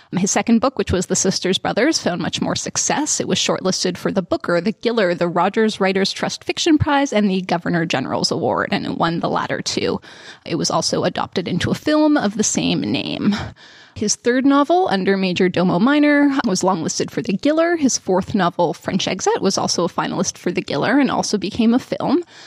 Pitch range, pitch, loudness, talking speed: 180-270 Hz, 200 Hz, -18 LUFS, 205 wpm